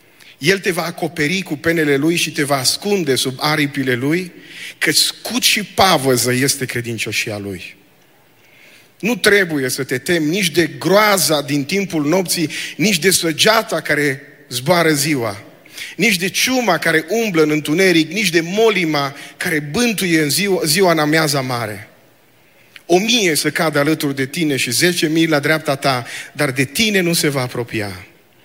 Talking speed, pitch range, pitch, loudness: 160 wpm, 140-180 Hz, 155 Hz, -16 LUFS